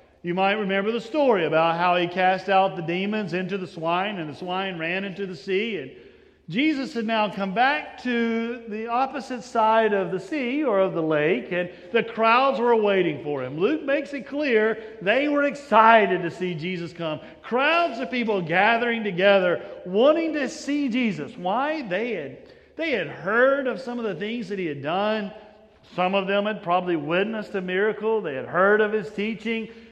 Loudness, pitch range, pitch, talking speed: -23 LUFS, 185-240 Hz, 215 Hz, 190 wpm